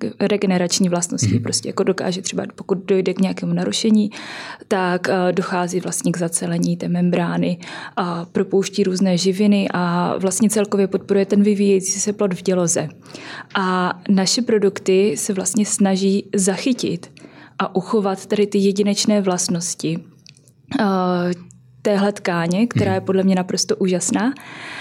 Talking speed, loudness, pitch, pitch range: 130 wpm, -19 LUFS, 195 Hz, 180-205 Hz